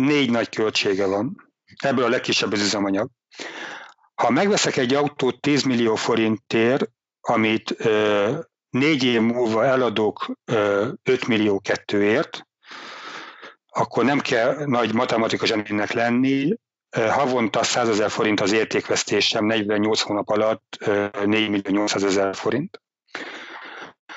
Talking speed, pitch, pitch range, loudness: 120 wpm, 115 Hz, 105-130 Hz, -21 LUFS